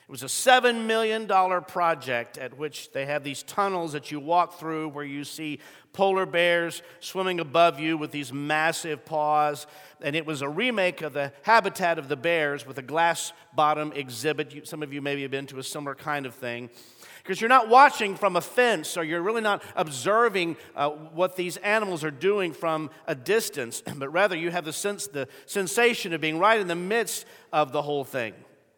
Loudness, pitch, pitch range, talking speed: -25 LUFS, 165 Hz, 150-190 Hz, 200 wpm